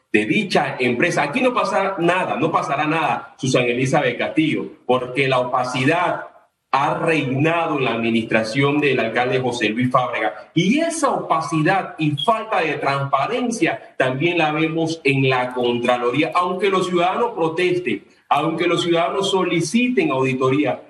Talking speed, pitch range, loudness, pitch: 140 wpm, 130-185 Hz, -19 LUFS, 160 Hz